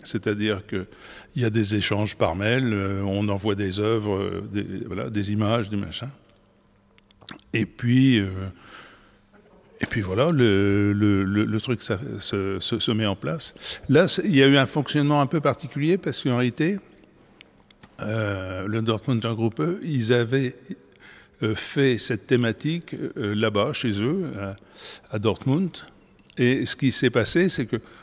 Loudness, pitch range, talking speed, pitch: -24 LUFS, 100-130 Hz, 155 wpm, 115 Hz